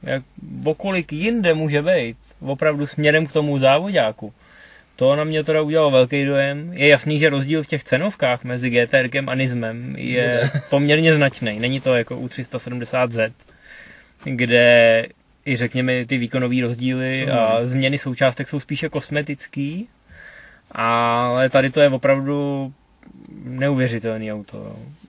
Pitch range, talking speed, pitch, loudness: 125-150 Hz, 130 wpm, 135 Hz, -19 LUFS